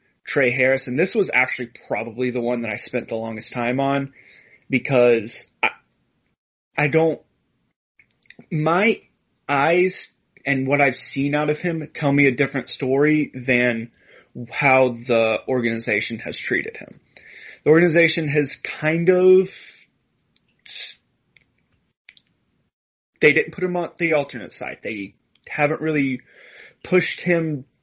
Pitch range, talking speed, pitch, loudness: 125-155 Hz, 125 wpm, 140 Hz, -20 LUFS